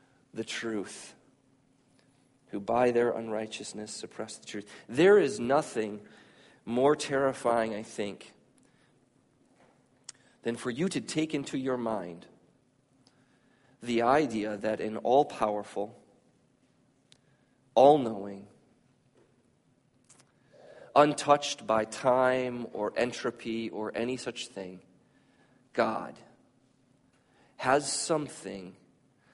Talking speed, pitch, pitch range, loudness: 85 wpm, 120 Hz, 105-130 Hz, -29 LUFS